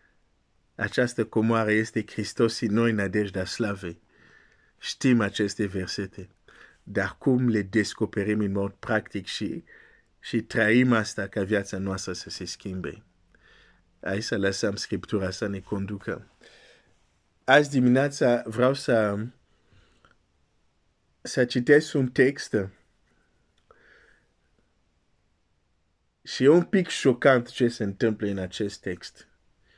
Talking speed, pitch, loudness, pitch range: 110 wpm, 105 Hz, -25 LUFS, 95-120 Hz